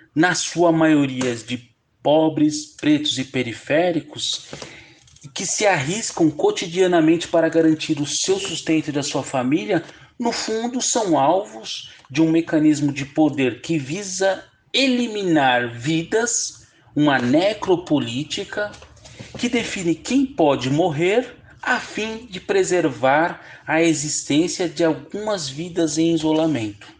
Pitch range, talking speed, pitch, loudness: 145-195 Hz, 115 wpm, 160 Hz, -20 LUFS